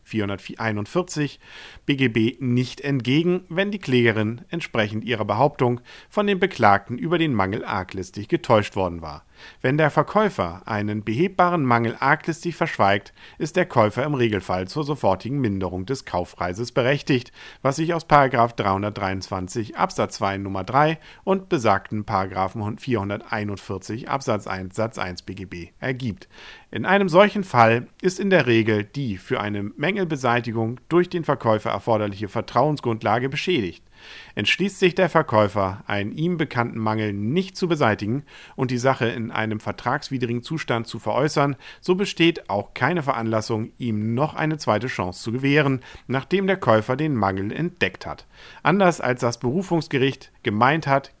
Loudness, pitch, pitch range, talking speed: -22 LUFS, 120 Hz, 105-155 Hz, 140 wpm